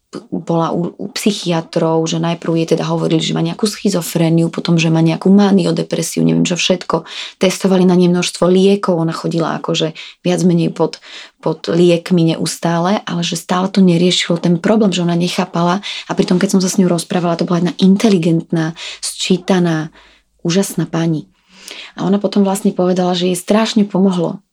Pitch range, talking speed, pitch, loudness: 165-190 Hz, 170 wpm, 175 Hz, -15 LUFS